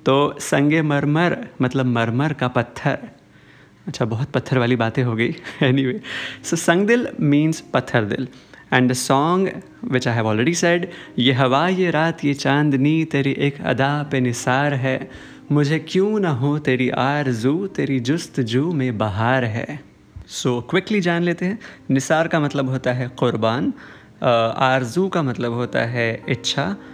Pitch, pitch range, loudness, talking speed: 135 Hz, 125-160 Hz, -20 LUFS, 160 wpm